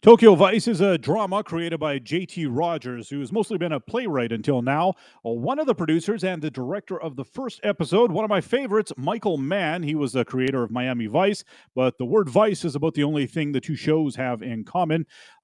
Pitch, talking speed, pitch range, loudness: 165 Hz, 215 wpm, 135-200 Hz, -23 LUFS